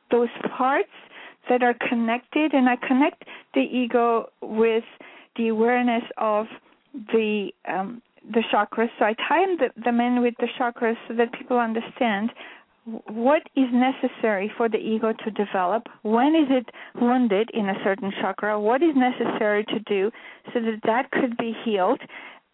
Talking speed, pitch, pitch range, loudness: 155 wpm, 235 Hz, 220-255 Hz, -23 LUFS